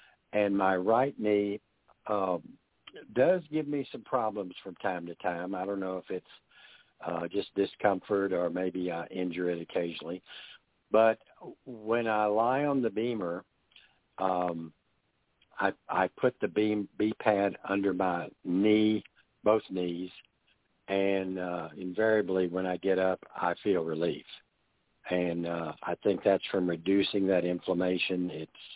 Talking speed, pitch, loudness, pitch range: 140 wpm, 95 Hz, -31 LUFS, 90-105 Hz